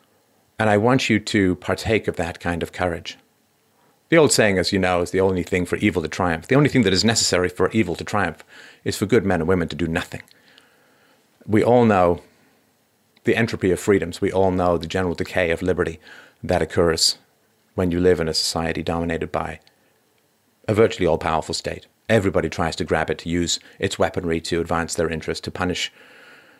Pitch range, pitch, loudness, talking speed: 85-105 Hz, 95 Hz, -21 LUFS, 200 wpm